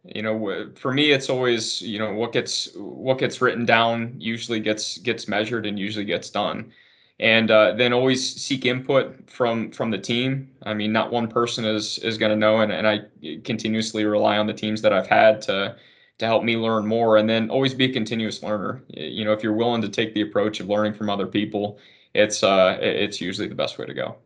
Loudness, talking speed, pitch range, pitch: -22 LUFS, 220 wpm, 105-120 Hz, 110 Hz